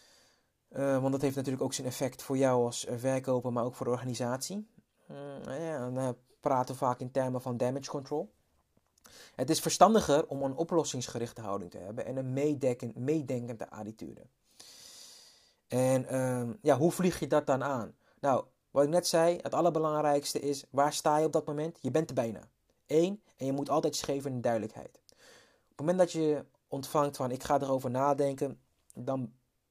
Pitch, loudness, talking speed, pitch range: 135 Hz, -31 LUFS, 180 wpm, 125-150 Hz